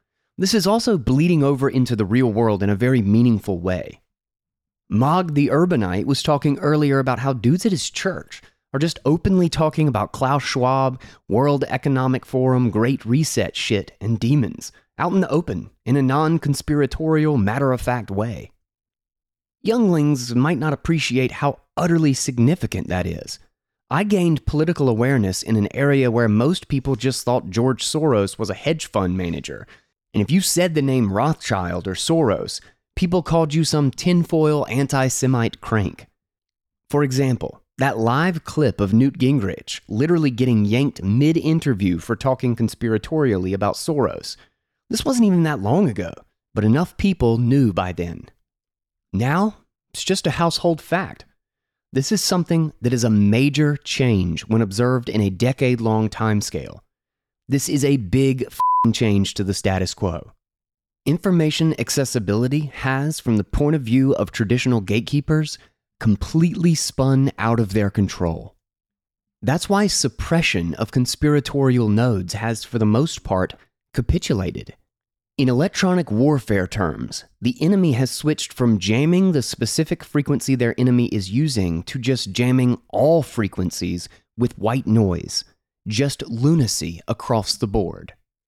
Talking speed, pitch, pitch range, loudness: 145 wpm, 130 Hz, 110-150 Hz, -20 LUFS